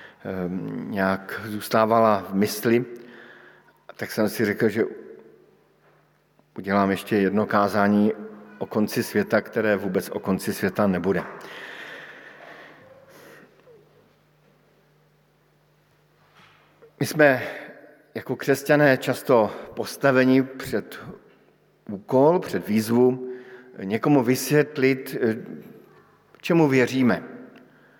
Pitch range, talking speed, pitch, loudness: 105-130 Hz, 75 wpm, 115 Hz, -22 LUFS